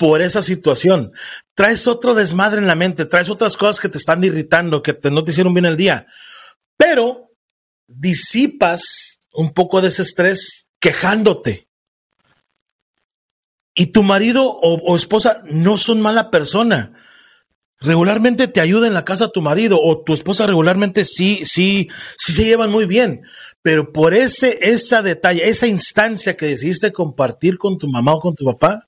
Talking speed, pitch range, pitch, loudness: 160 wpm, 165-215 Hz, 185 Hz, -14 LUFS